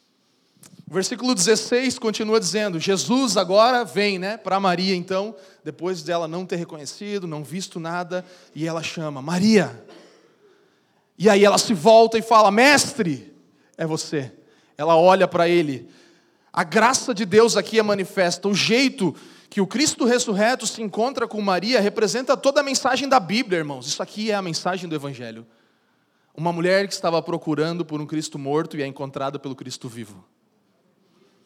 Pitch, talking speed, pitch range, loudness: 190 Hz, 160 wpm, 165-220 Hz, -20 LUFS